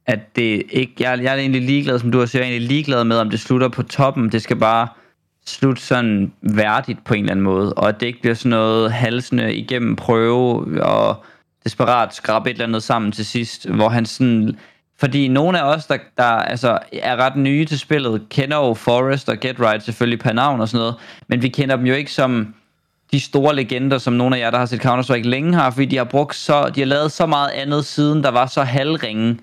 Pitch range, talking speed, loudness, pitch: 115-135 Hz, 235 wpm, -18 LUFS, 125 Hz